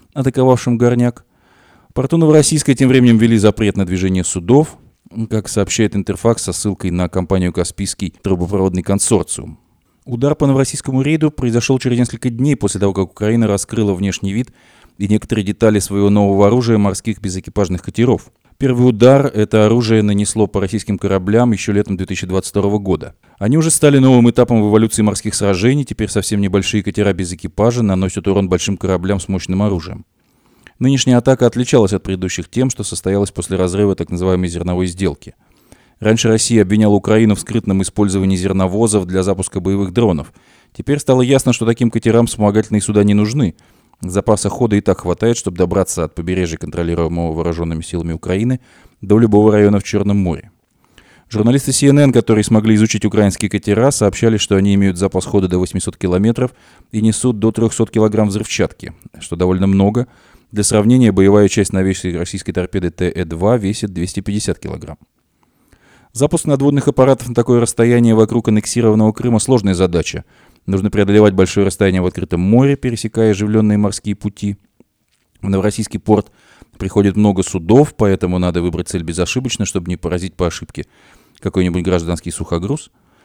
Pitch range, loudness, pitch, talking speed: 95-115 Hz, -15 LUFS, 105 Hz, 150 wpm